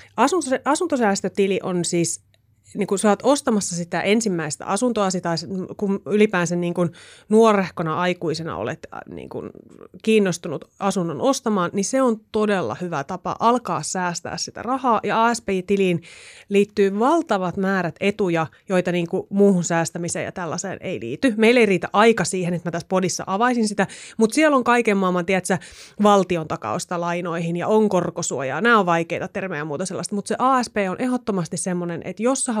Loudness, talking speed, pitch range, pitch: -21 LUFS, 160 wpm, 175-215 Hz, 190 Hz